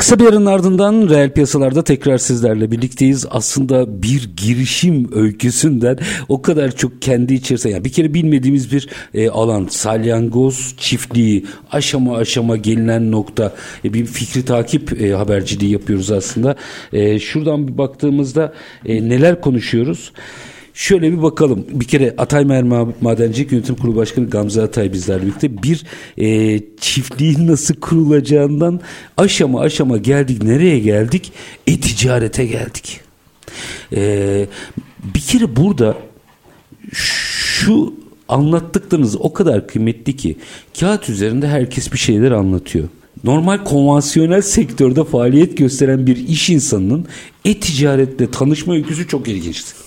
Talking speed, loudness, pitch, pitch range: 120 wpm, -15 LUFS, 130 Hz, 115-150 Hz